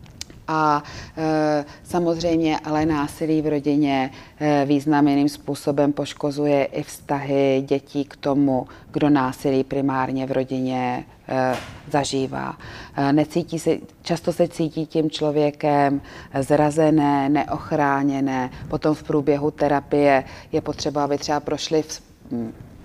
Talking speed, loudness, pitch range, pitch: 115 wpm, -22 LUFS, 140-155 Hz, 145 Hz